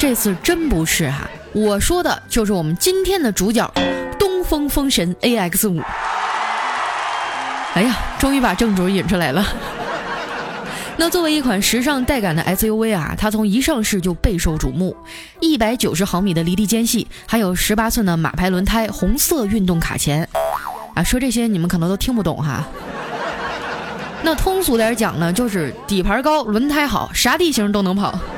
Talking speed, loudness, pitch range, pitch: 260 characters per minute, -18 LUFS, 180-250 Hz, 215 Hz